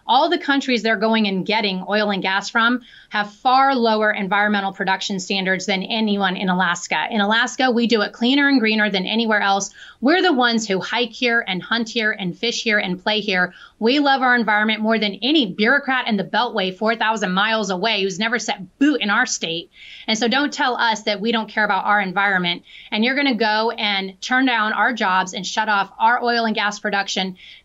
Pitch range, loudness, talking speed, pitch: 200-235 Hz, -19 LUFS, 215 wpm, 215 Hz